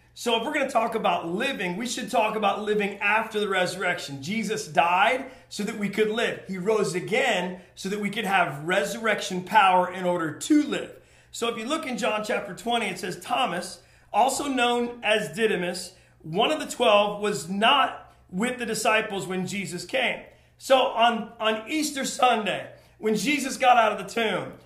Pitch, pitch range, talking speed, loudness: 215 Hz, 190-235 Hz, 185 wpm, -25 LUFS